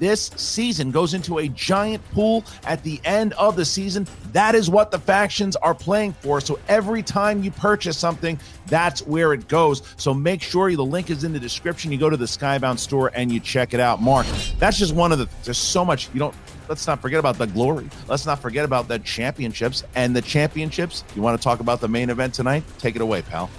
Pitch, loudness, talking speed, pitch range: 155 Hz, -21 LUFS, 230 wpm, 125-185 Hz